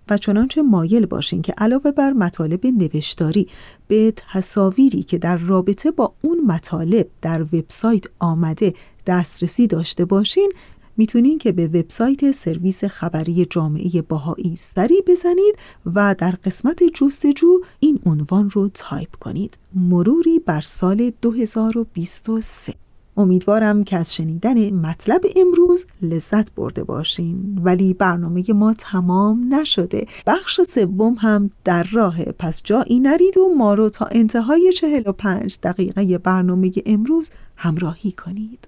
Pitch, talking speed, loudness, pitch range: 200 Hz, 125 wpm, -17 LUFS, 175-240 Hz